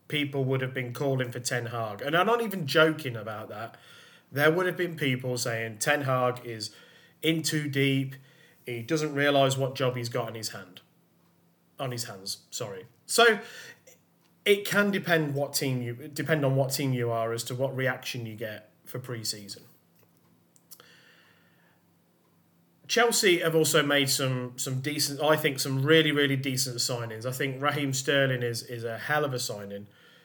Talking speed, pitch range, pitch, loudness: 175 wpm, 120-150 Hz, 135 Hz, -27 LUFS